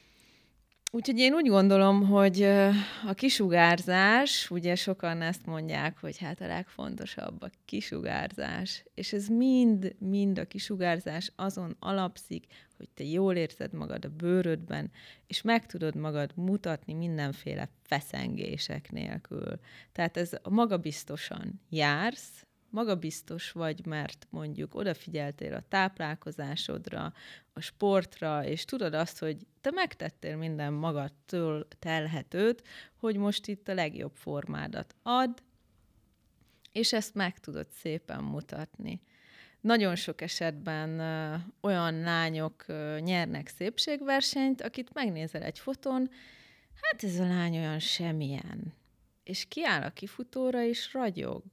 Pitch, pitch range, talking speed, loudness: 185 Hz, 160-210 Hz, 115 wpm, -31 LUFS